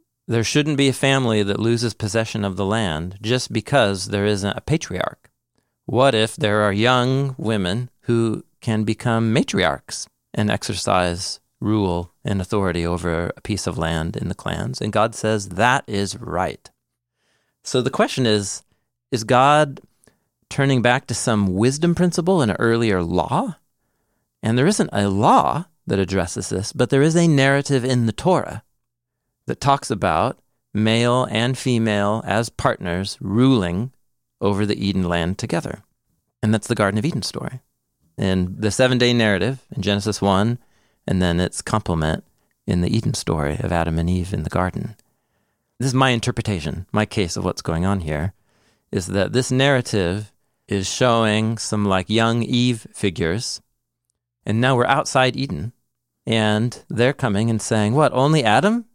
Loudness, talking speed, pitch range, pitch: -20 LUFS, 160 wpm, 100-125 Hz, 110 Hz